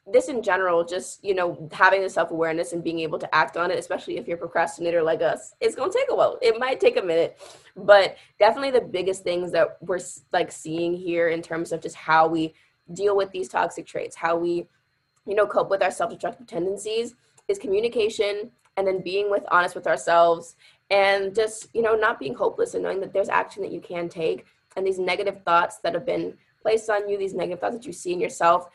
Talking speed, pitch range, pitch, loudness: 220 wpm, 170-220 Hz, 190 Hz, -24 LUFS